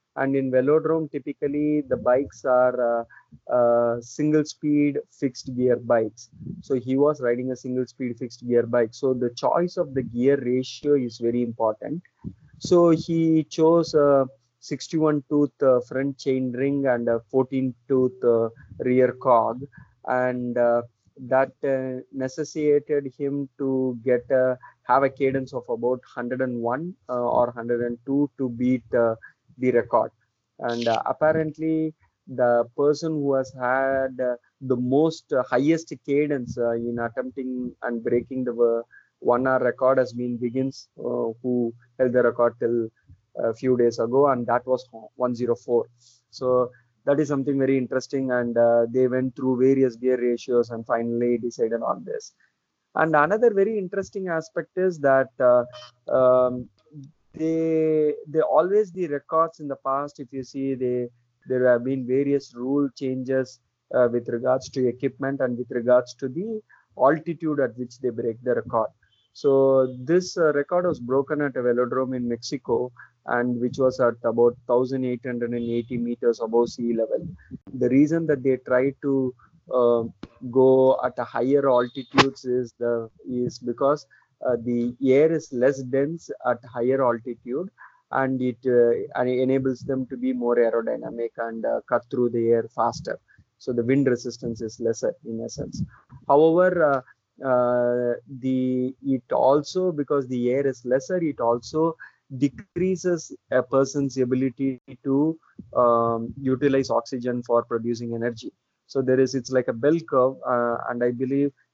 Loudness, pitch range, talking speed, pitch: -24 LUFS, 120-140 Hz, 155 wpm, 130 Hz